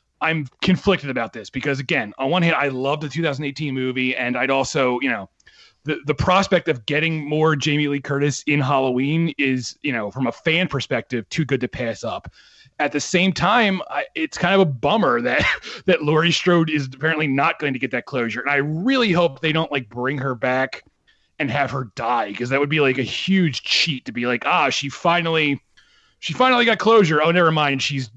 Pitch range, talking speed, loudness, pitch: 130-165 Hz, 215 wpm, -20 LUFS, 145 Hz